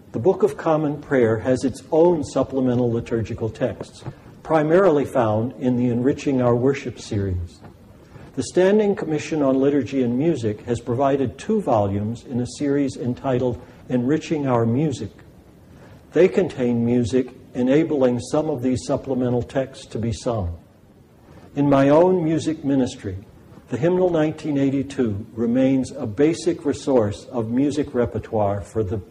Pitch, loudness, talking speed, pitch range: 130 Hz, -21 LUFS, 135 wpm, 120-145 Hz